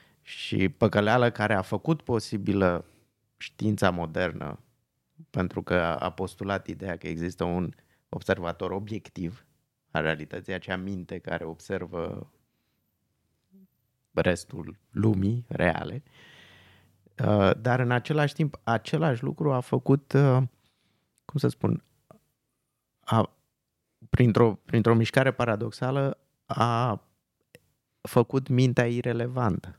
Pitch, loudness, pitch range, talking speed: 110 Hz, -27 LUFS, 95-125 Hz, 95 wpm